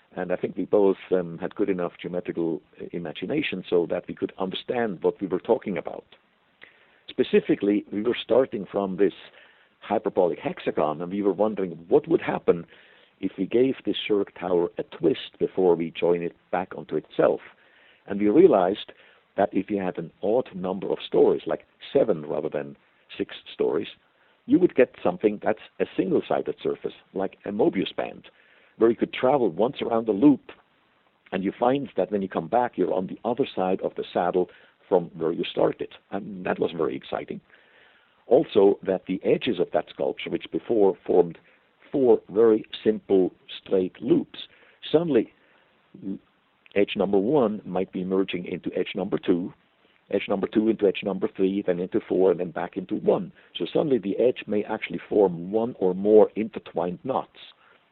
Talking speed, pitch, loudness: 175 wpm, 105 Hz, -25 LUFS